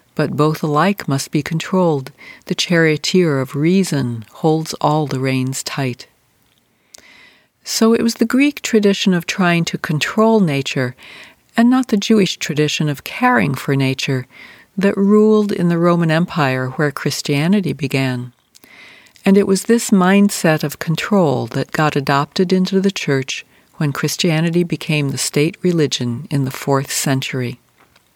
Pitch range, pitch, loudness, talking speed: 140-190 Hz, 155 Hz, -16 LUFS, 145 wpm